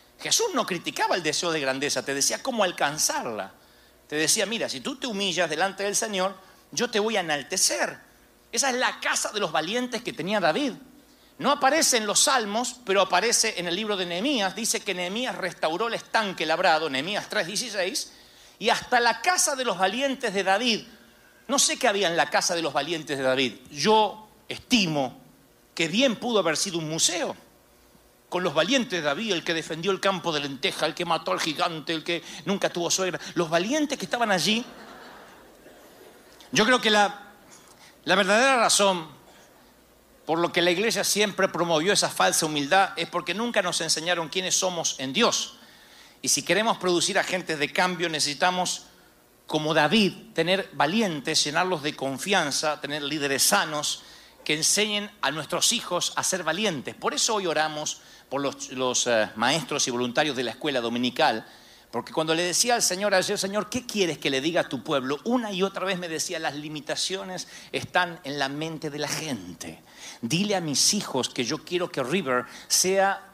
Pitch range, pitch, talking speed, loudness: 150-205 Hz, 180 Hz, 180 wpm, -24 LUFS